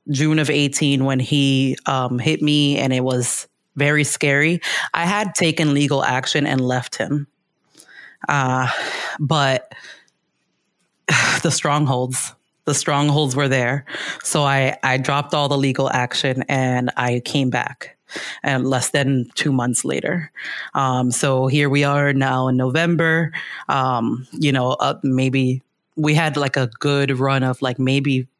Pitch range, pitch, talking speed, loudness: 130-145 Hz, 140 Hz, 145 wpm, -19 LUFS